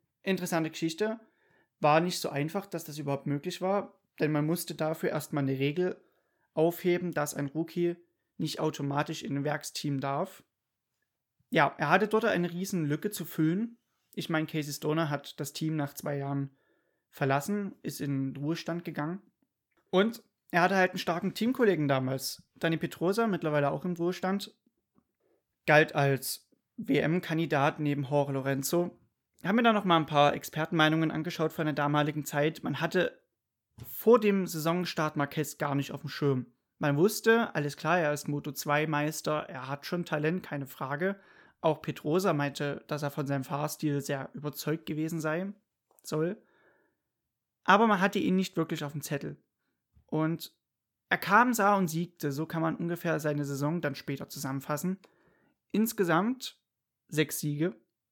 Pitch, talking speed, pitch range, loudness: 155 Hz, 155 wpm, 145-180 Hz, -30 LUFS